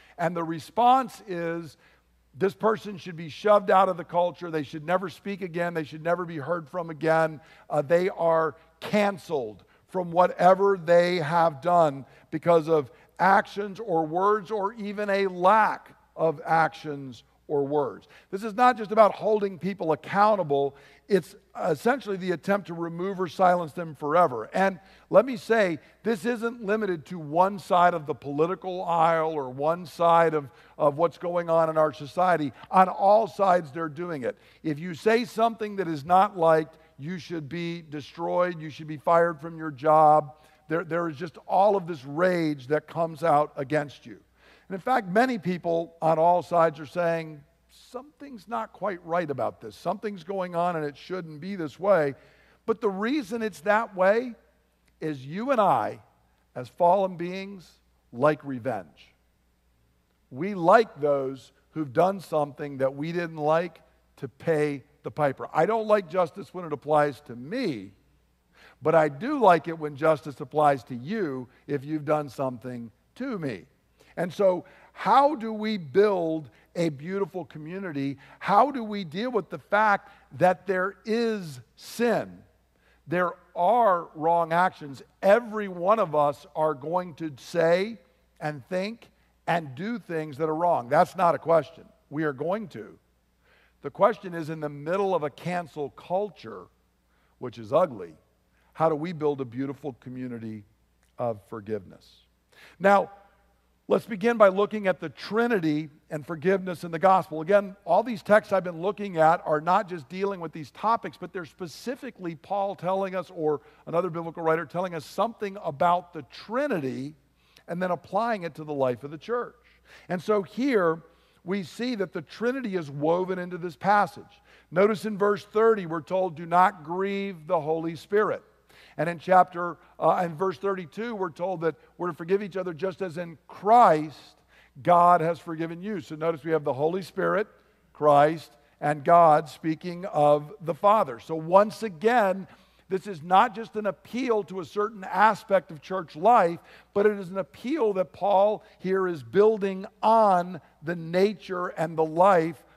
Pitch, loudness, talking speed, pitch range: 175 Hz, -26 LUFS, 165 wpm, 155-195 Hz